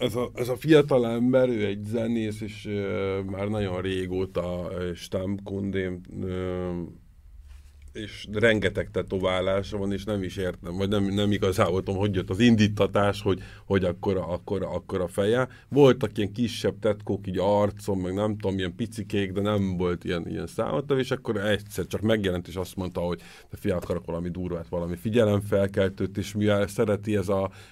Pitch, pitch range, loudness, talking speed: 100 Hz, 95-105 Hz, -26 LUFS, 165 wpm